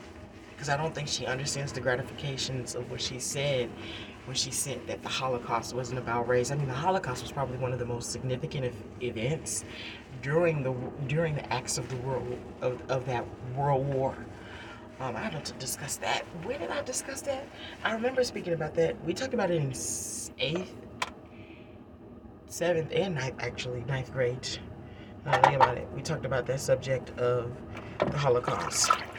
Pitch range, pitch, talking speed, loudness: 120-140 Hz, 125 Hz, 180 wpm, -31 LUFS